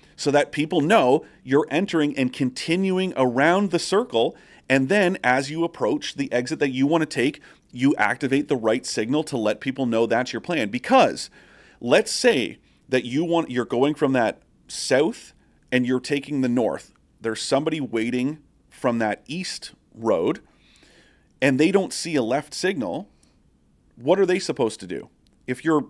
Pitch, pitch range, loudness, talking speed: 140 Hz, 125-160 Hz, -22 LUFS, 170 wpm